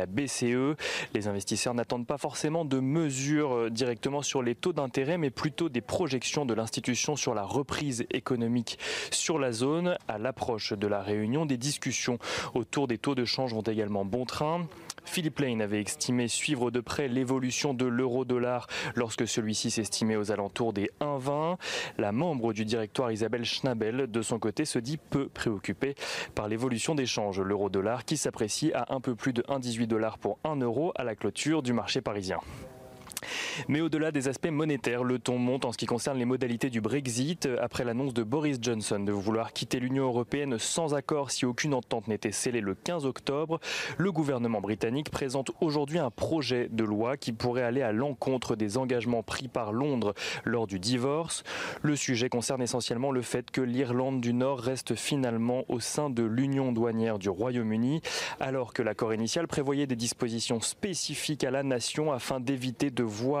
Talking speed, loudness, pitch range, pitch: 180 wpm, -30 LUFS, 115-140 Hz, 125 Hz